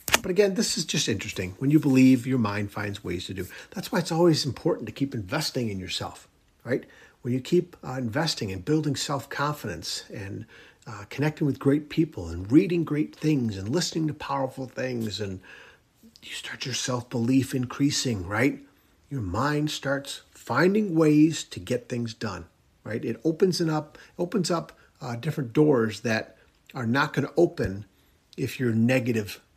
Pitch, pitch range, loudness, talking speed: 135 Hz, 115-155 Hz, -26 LUFS, 170 wpm